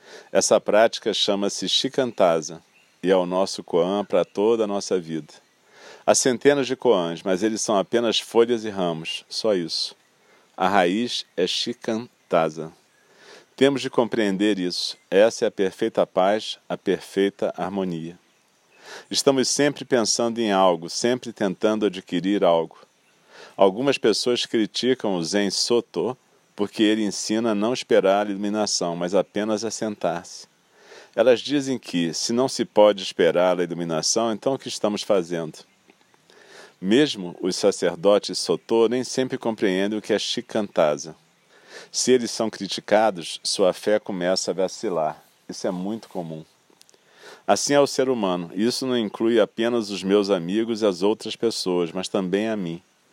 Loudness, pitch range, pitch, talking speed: -22 LUFS, 95-115 Hz, 105 Hz, 145 wpm